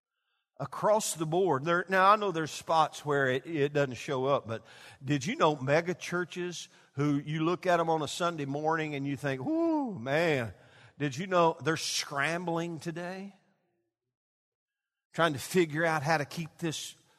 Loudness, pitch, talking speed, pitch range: -30 LUFS, 160 Hz, 170 wpm, 145-175 Hz